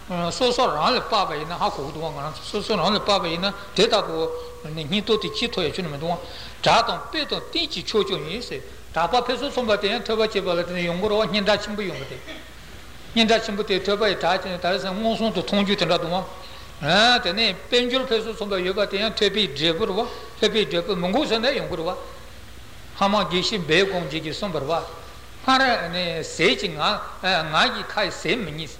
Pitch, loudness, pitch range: 205 Hz, -22 LUFS, 180-225 Hz